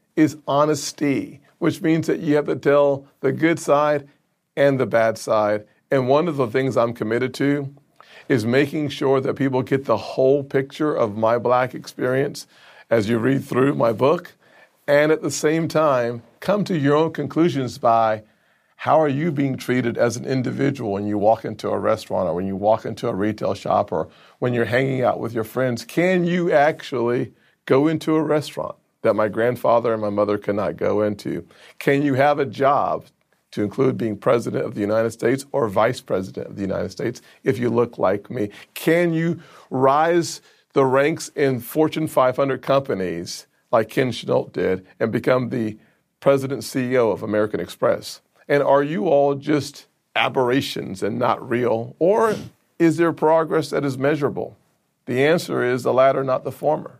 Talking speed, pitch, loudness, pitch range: 180 wpm, 135 Hz, -21 LUFS, 120-150 Hz